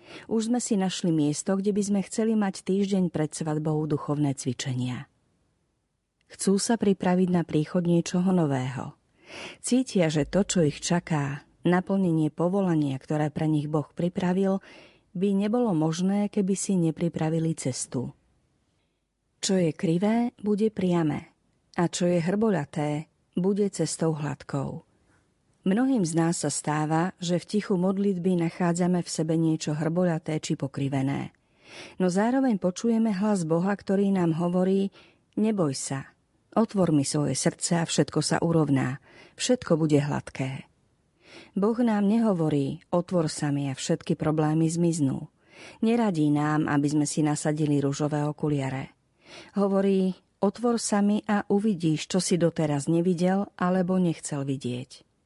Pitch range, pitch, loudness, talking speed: 150-195 Hz, 170 Hz, -26 LUFS, 130 wpm